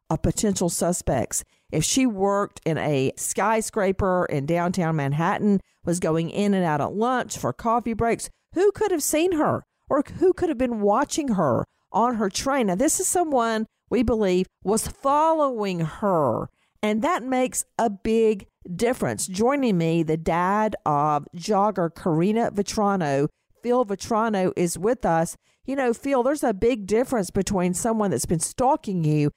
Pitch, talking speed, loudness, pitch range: 205 Hz, 160 wpm, -23 LUFS, 175-245 Hz